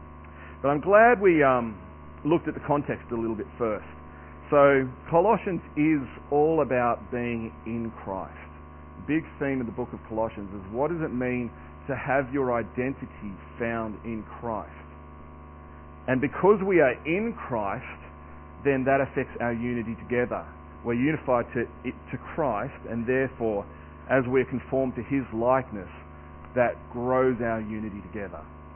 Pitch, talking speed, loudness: 115 Hz, 150 wpm, -26 LUFS